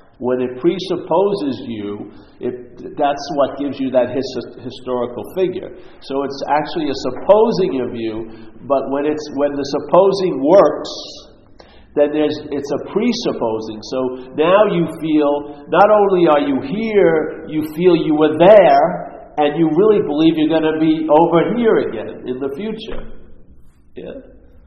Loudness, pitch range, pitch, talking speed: -16 LUFS, 130-170 Hz, 145 Hz, 150 wpm